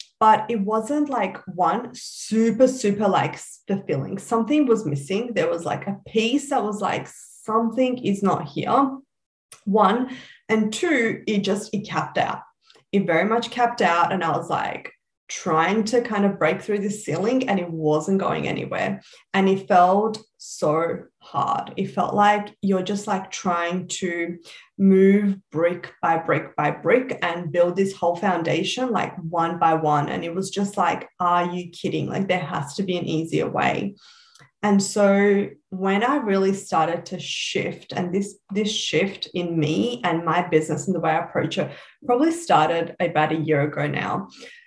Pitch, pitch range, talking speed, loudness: 195 Hz, 175-220 Hz, 170 wpm, -22 LUFS